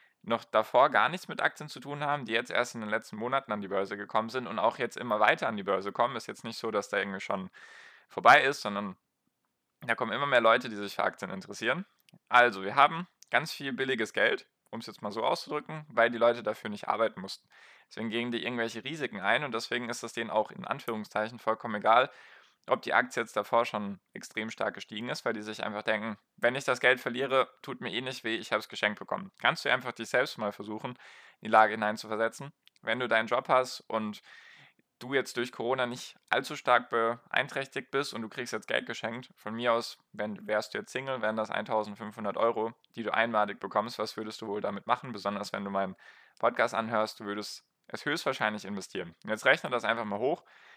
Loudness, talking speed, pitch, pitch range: -30 LUFS, 220 wpm, 115 Hz, 105-120 Hz